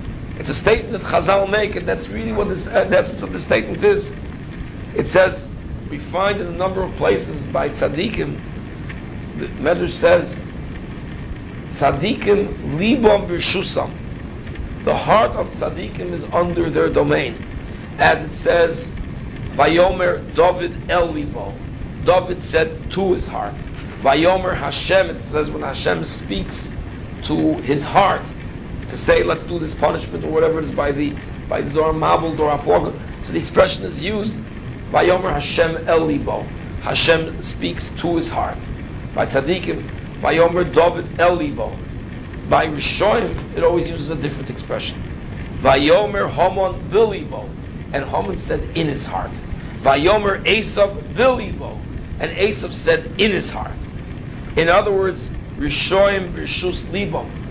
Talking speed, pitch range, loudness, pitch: 145 wpm, 150-195 Hz, -19 LUFS, 170 Hz